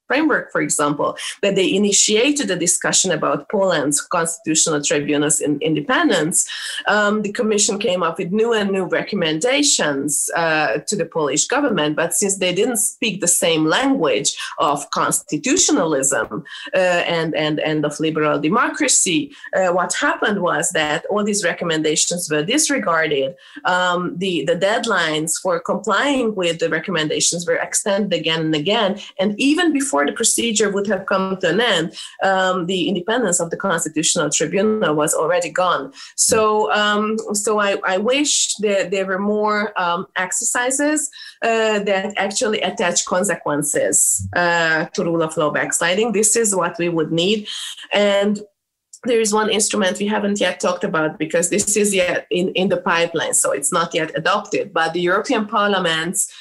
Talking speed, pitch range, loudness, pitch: 160 wpm, 165-215 Hz, -18 LUFS, 190 Hz